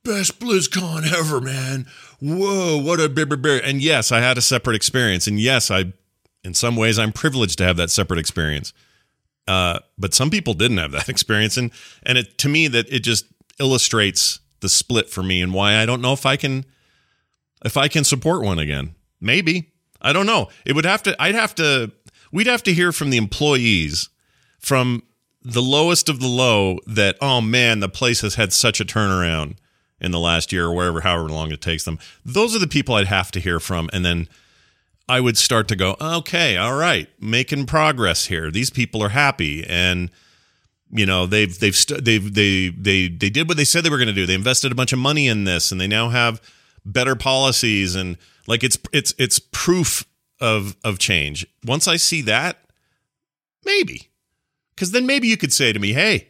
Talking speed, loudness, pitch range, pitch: 200 wpm, -18 LUFS, 95-145 Hz, 120 Hz